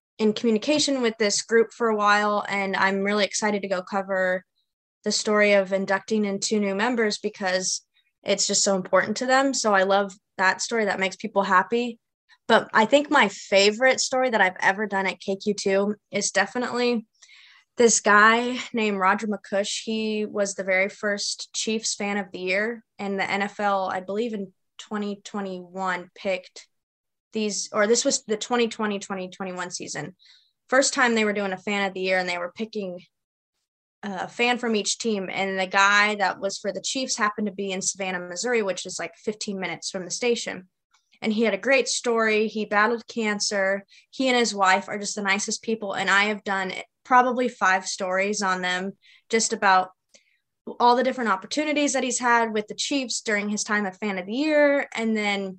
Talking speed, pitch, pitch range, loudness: 190 wpm, 205 Hz, 190-225 Hz, -23 LUFS